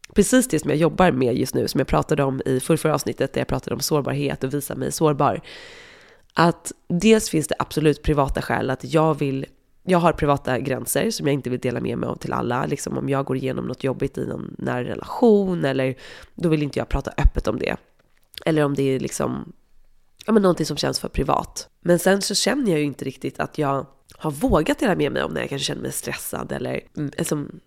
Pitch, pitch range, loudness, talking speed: 150 Hz, 135-175 Hz, -22 LUFS, 225 wpm